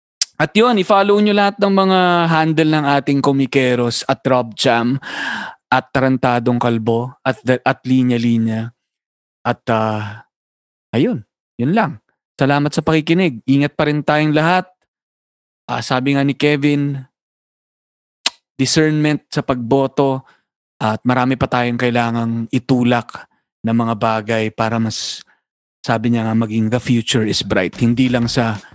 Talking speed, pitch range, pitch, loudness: 135 wpm, 115-145 Hz, 130 Hz, -16 LUFS